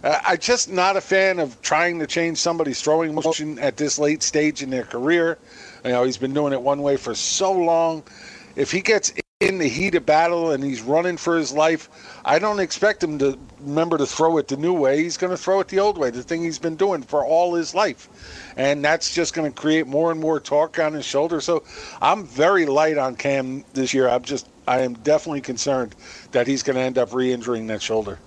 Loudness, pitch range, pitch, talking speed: -21 LUFS, 135-170 Hz, 155 Hz, 230 wpm